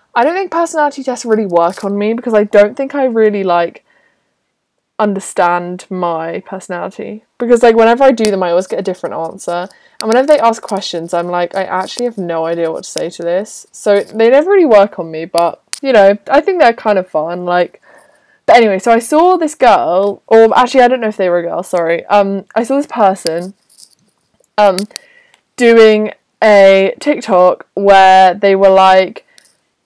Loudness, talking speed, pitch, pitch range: -11 LUFS, 195 wpm, 205 Hz, 180-240 Hz